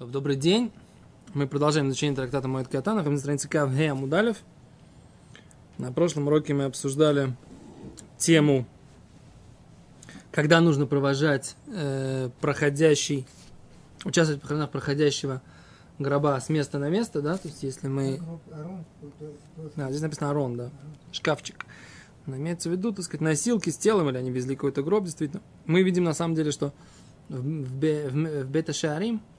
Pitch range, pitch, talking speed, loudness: 140-165 Hz, 150 Hz, 135 wpm, -26 LUFS